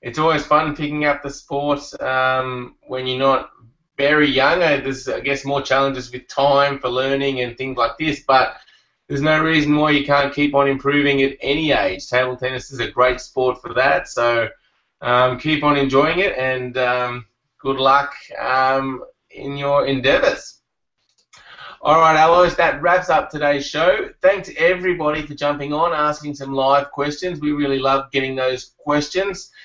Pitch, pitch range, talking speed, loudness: 140 Hz, 130-150 Hz, 170 wpm, -18 LUFS